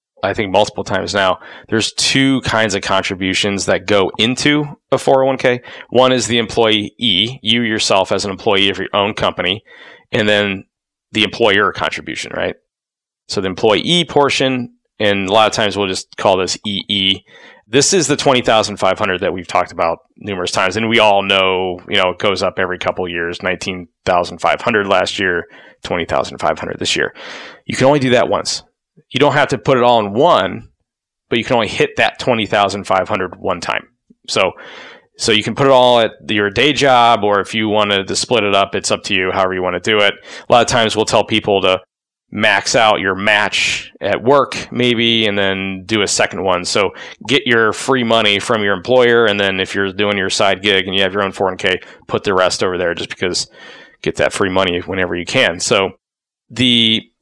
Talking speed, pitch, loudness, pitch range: 210 wpm, 105 Hz, -15 LUFS, 95-120 Hz